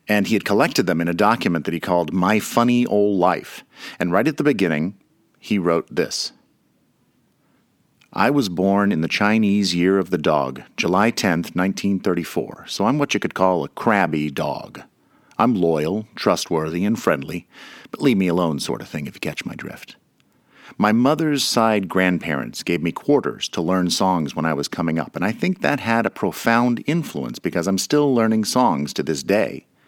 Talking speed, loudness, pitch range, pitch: 185 wpm, -20 LUFS, 90-115 Hz, 95 Hz